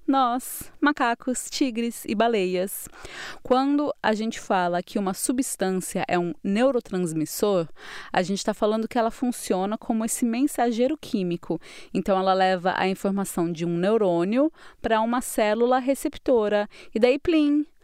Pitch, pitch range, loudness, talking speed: 225 Hz, 190-255 Hz, -24 LUFS, 140 wpm